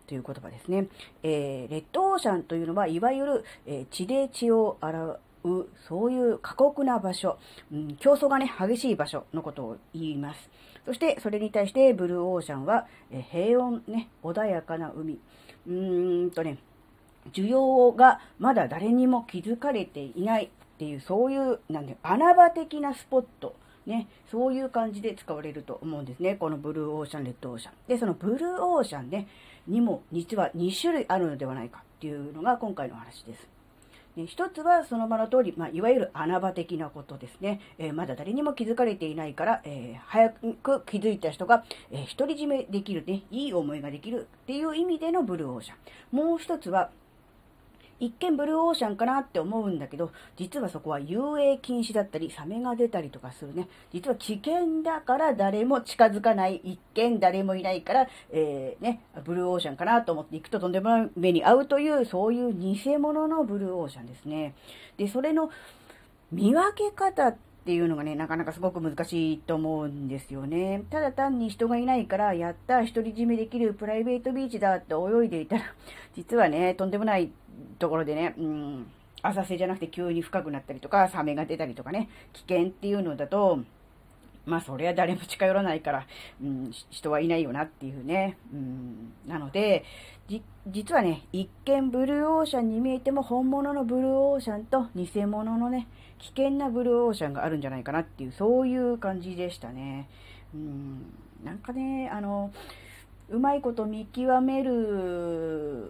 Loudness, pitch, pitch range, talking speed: -28 LUFS, 190 Hz, 155-245 Hz, 365 characters per minute